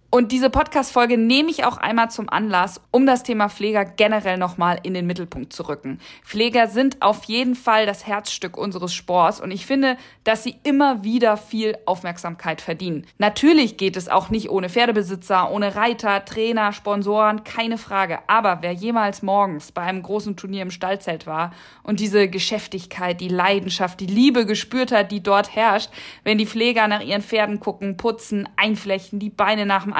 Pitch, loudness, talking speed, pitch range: 205 Hz, -20 LUFS, 175 wpm, 190-225 Hz